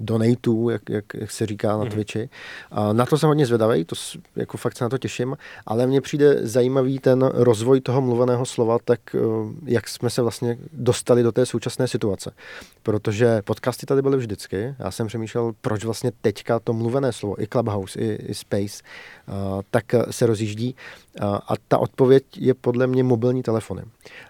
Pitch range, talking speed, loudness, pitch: 110-125 Hz, 180 wpm, -22 LUFS, 120 Hz